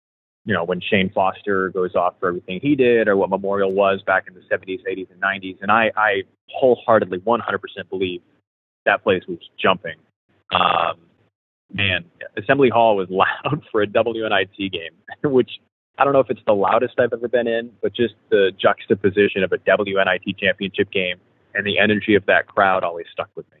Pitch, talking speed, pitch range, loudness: 100 Hz, 185 wpm, 95-110 Hz, -19 LUFS